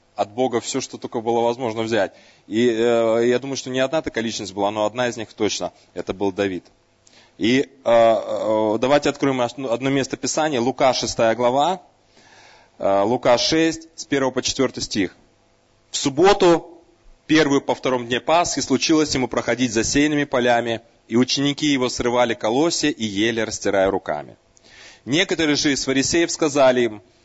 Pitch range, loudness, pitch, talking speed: 115-140 Hz, -20 LUFS, 125 Hz, 160 wpm